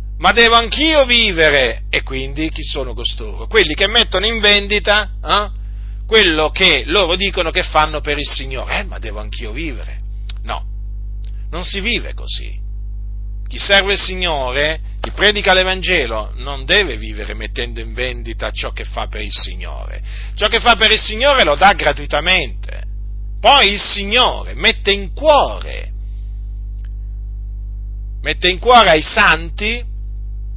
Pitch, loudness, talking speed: 135 Hz, -13 LUFS, 145 wpm